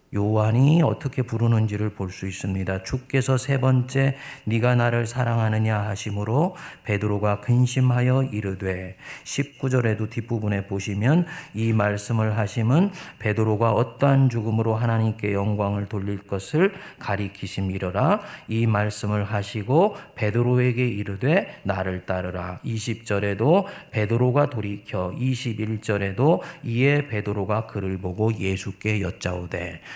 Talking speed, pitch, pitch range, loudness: 285 characters per minute, 110 Hz, 100-130 Hz, -24 LUFS